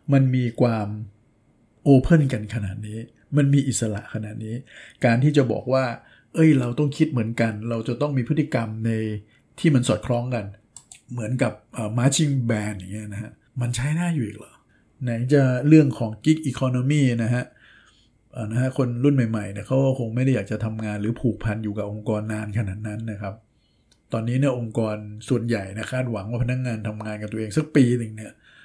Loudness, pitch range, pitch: -23 LUFS, 110-130 Hz, 120 Hz